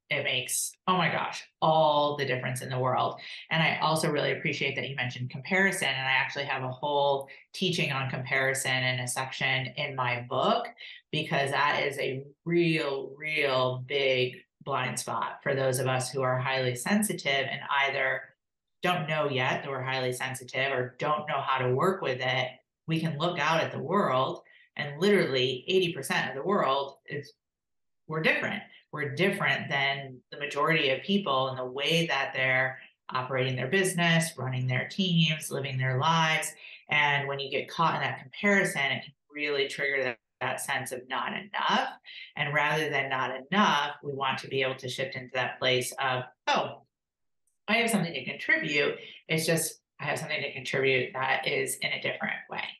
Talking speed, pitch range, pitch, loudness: 180 wpm, 130-160 Hz, 140 Hz, -28 LUFS